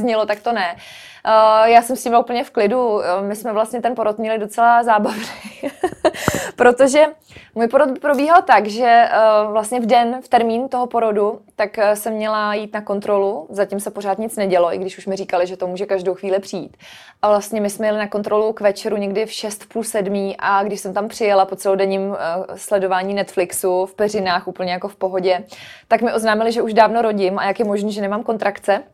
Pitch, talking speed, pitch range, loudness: 210 Hz, 200 wpm, 195-230 Hz, -18 LUFS